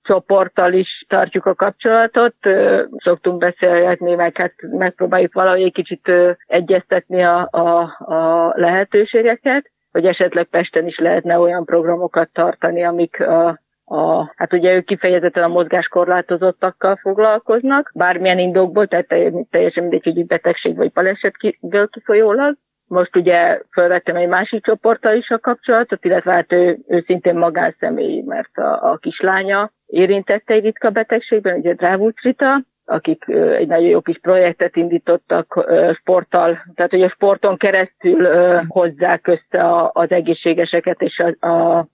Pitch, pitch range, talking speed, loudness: 180 Hz, 175-200 Hz, 130 wpm, -15 LUFS